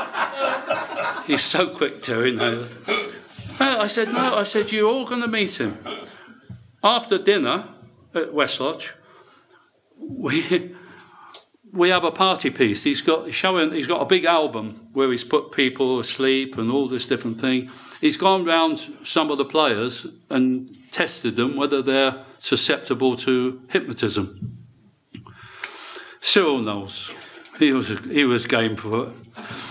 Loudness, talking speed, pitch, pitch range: -21 LUFS, 140 wpm, 145 Hz, 130-190 Hz